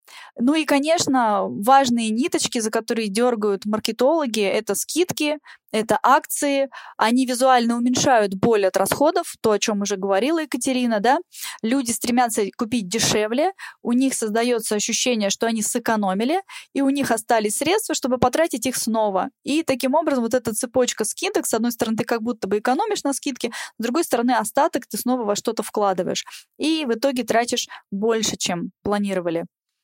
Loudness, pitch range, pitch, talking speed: -21 LUFS, 220-280 Hz, 245 Hz, 160 wpm